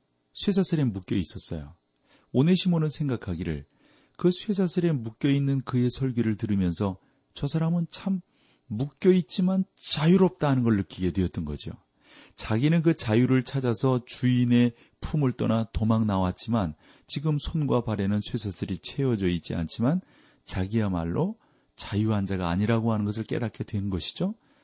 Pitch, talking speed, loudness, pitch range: 120 Hz, 315 characters per minute, -27 LUFS, 100-150 Hz